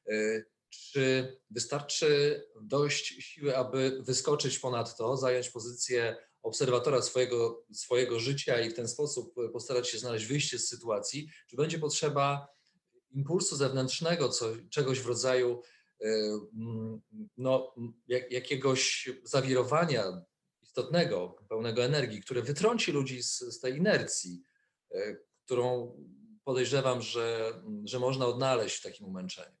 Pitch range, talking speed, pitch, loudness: 120-145 Hz, 115 wpm, 130 Hz, -32 LUFS